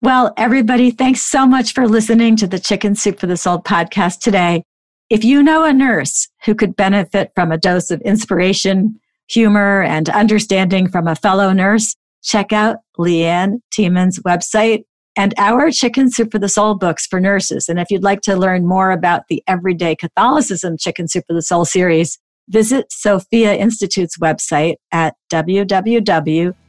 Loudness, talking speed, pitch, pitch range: -14 LUFS, 165 wpm, 195 Hz, 180-220 Hz